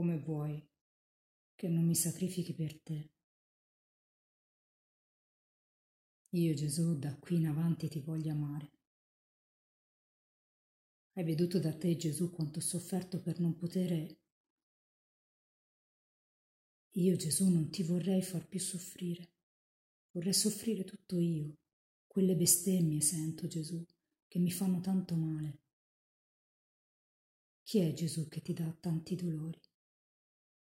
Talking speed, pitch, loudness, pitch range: 110 wpm, 165 Hz, -35 LUFS, 155-180 Hz